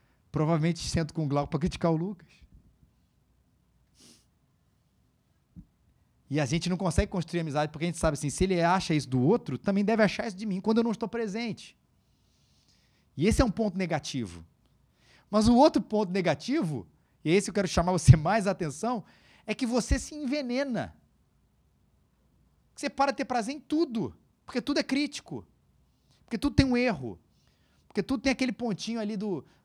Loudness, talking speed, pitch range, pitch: -28 LUFS, 175 wpm, 165-240 Hz, 200 Hz